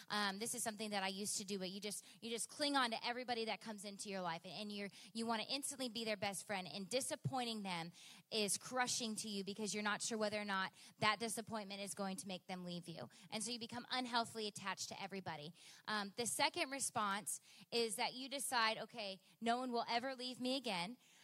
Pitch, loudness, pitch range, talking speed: 215 Hz, -42 LUFS, 195-235 Hz, 225 wpm